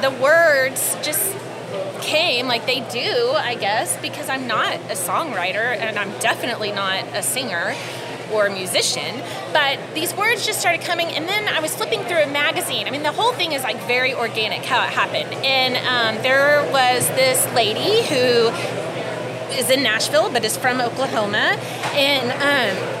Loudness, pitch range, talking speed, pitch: -19 LUFS, 250-335 Hz, 170 wpm, 275 Hz